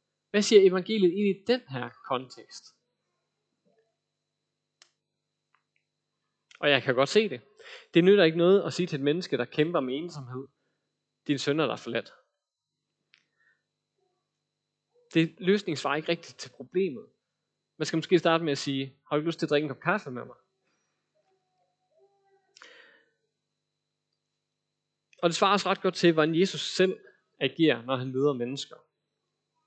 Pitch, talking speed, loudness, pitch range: 170 Hz, 150 wpm, -27 LUFS, 145-200 Hz